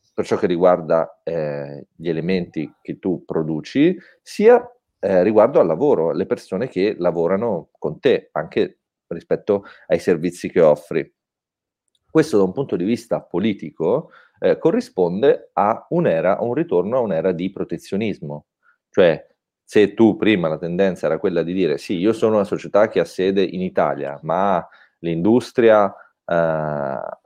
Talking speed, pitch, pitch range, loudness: 150 wpm, 95 Hz, 80-125 Hz, -19 LUFS